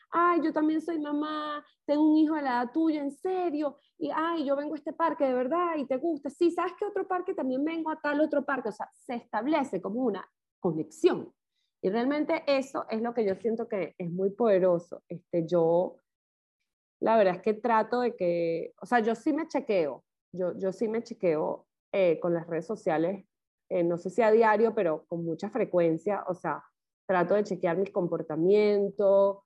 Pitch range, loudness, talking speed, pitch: 190-305 Hz, -28 LUFS, 200 wpm, 230 Hz